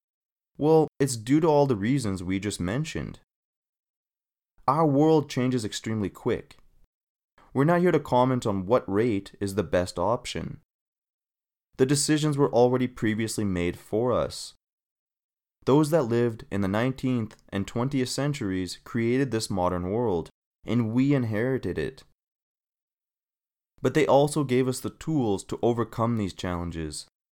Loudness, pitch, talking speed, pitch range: -26 LUFS, 120 Hz, 140 wpm, 100-140 Hz